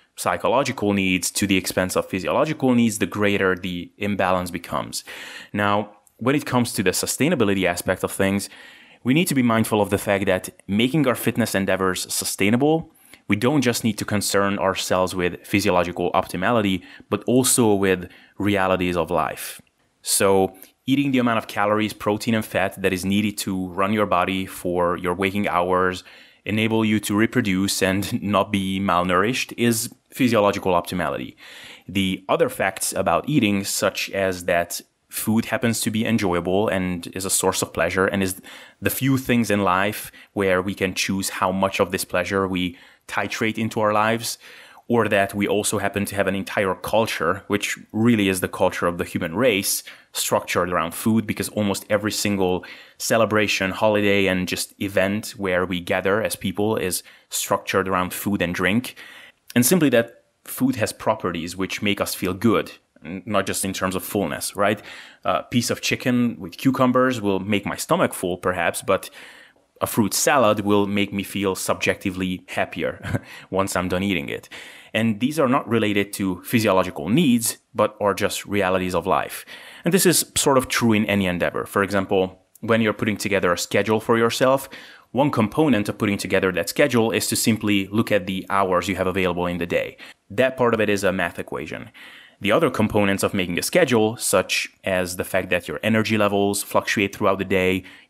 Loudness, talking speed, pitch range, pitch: -21 LUFS, 180 wpm, 95-110 Hz, 100 Hz